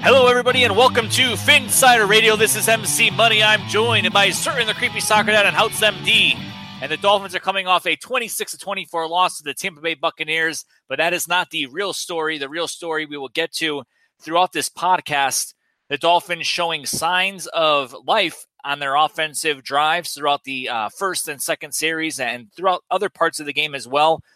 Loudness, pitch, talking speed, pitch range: -18 LUFS, 165 Hz, 195 wpm, 150-200 Hz